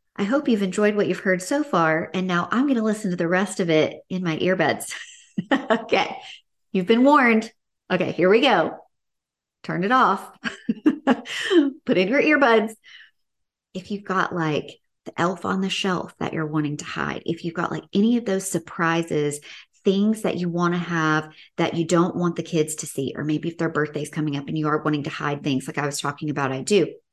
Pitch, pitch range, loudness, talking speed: 180 Hz, 155-220 Hz, -22 LUFS, 210 wpm